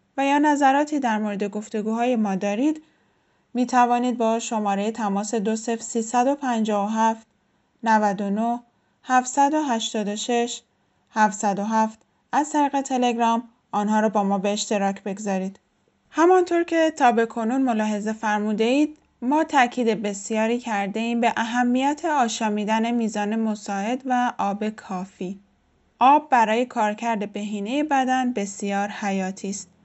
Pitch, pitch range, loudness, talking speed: 225 Hz, 210-250 Hz, -23 LUFS, 105 wpm